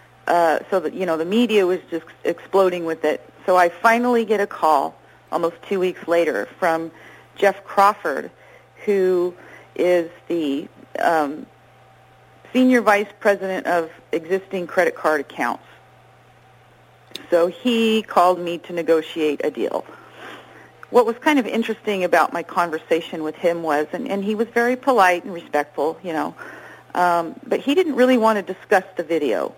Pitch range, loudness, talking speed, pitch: 165-215 Hz, -20 LUFS, 155 wpm, 180 Hz